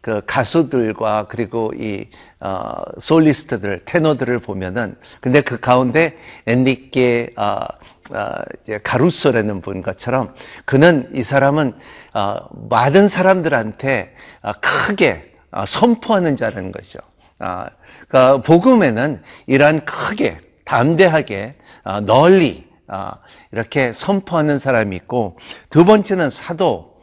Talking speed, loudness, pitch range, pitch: 240 characters per minute, -16 LUFS, 115-155 Hz, 130 Hz